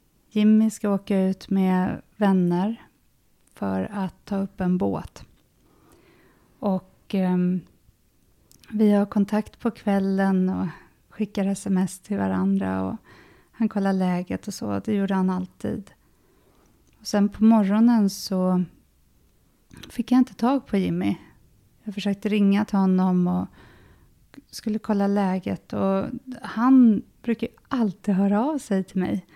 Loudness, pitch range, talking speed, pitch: -24 LUFS, 185-215 Hz, 130 wpm, 195 Hz